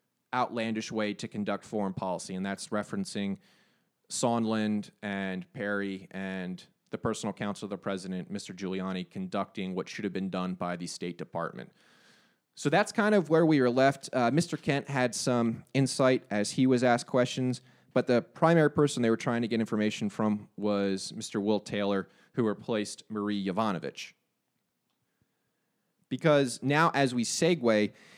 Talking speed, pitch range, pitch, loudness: 160 wpm, 100-130 Hz, 110 Hz, -30 LUFS